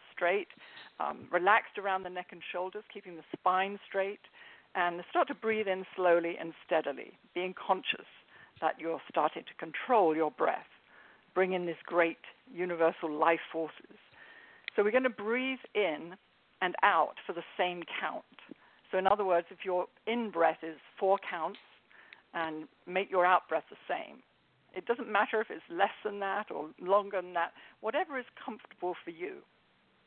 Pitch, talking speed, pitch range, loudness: 185 Hz, 165 wpm, 175-215 Hz, -33 LUFS